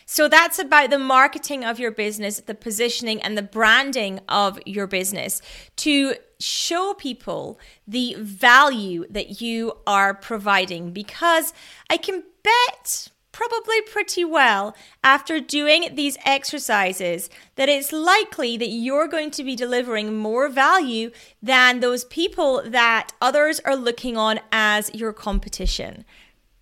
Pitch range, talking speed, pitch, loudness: 215-300 Hz, 130 wpm, 245 Hz, -20 LUFS